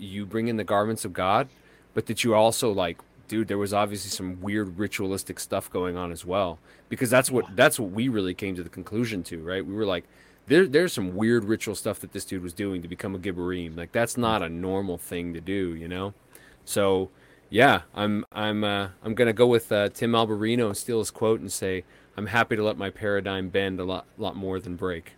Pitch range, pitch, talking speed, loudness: 95-110 Hz, 100 Hz, 230 wpm, -26 LUFS